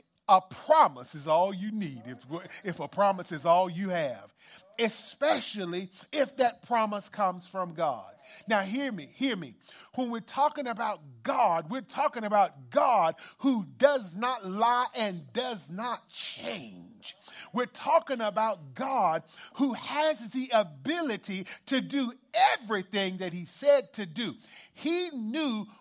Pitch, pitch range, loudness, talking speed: 220 Hz, 185-260 Hz, -29 LUFS, 140 wpm